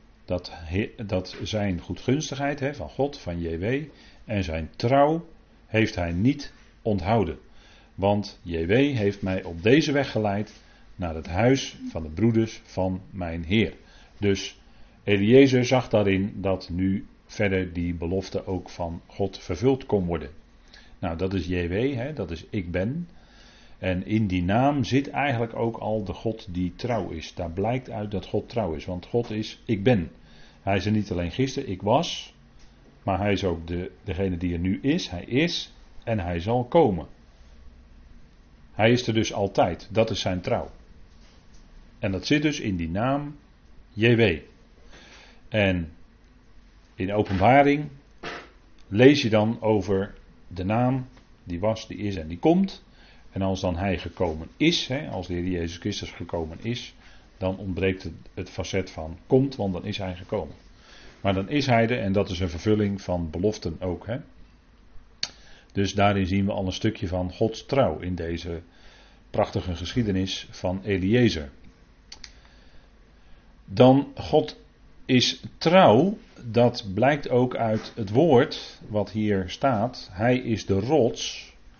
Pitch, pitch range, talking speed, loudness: 100 Hz, 90-115 Hz, 155 wpm, -25 LUFS